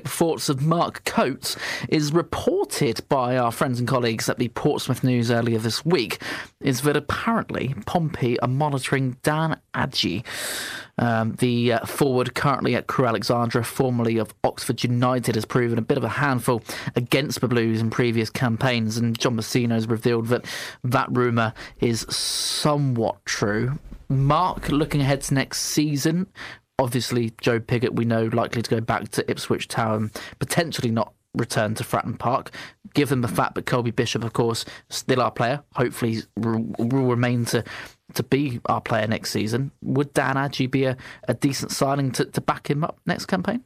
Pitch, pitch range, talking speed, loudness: 125 Hz, 115-140 Hz, 170 wpm, -23 LUFS